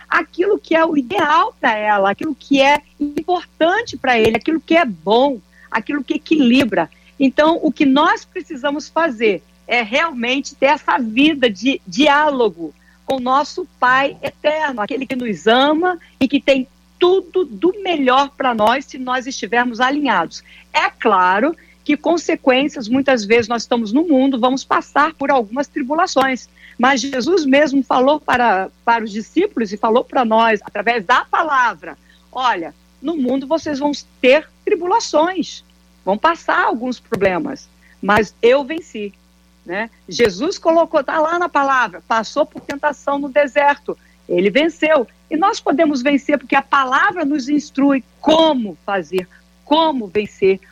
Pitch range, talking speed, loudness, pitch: 235-310 Hz, 150 wpm, -16 LUFS, 275 Hz